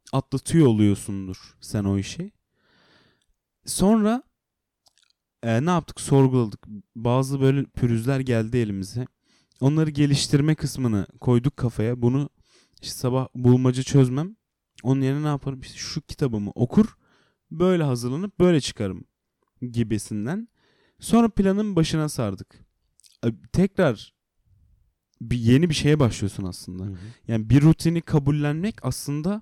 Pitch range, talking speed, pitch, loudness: 115-155 Hz, 110 wpm, 130 Hz, -23 LUFS